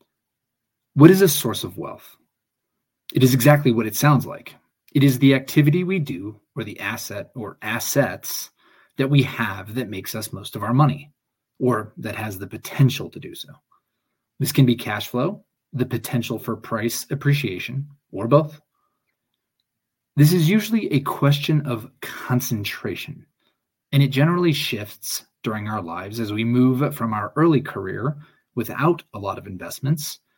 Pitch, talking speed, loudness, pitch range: 130 Hz, 160 wpm, -21 LUFS, 115-145 Hz